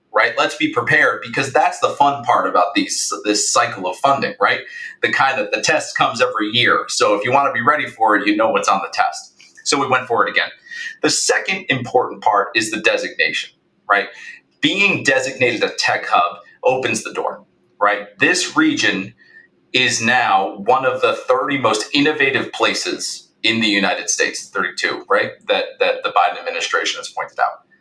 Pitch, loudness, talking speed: 375 Hz, -17 LUFS, 190 wpm